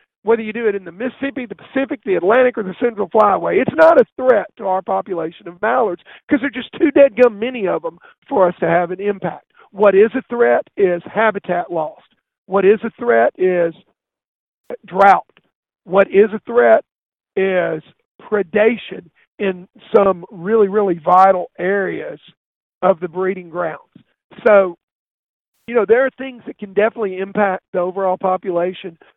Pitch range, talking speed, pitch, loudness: 185-235 Hz, 170 wpm, 200 Hz, -16 LUFS